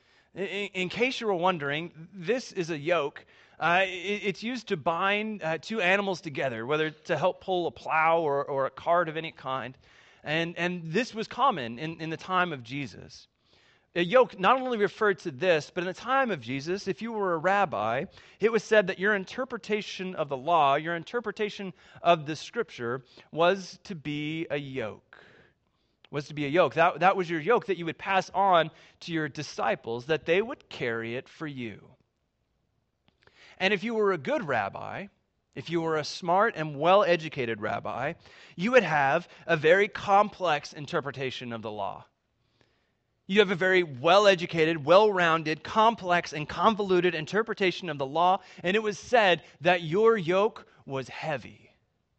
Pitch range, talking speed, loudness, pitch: 155-200 Hz, 175 wpm, -27 LUFS, 175 Hz